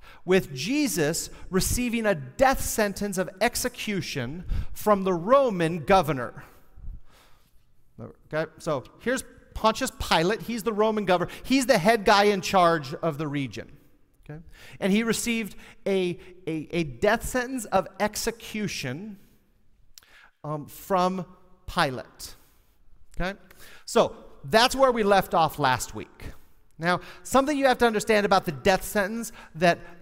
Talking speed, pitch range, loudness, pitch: 130 wpm, 160-225 Hz, -25 LUFS, 190 Hz